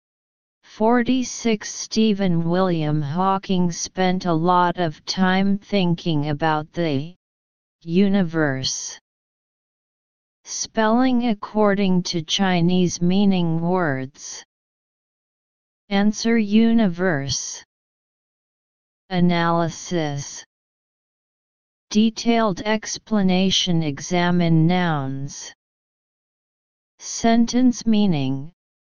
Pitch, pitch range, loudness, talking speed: 180 Hz, 165-210 Hz, -20 LUFS, 60 wpm